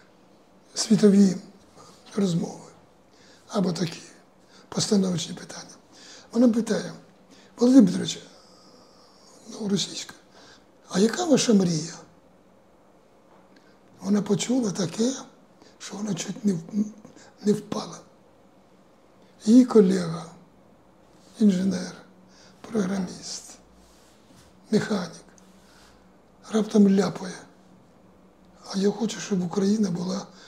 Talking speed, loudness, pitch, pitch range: 75 wpm, -24 LUFS, 200 Hz, 190-220 Hz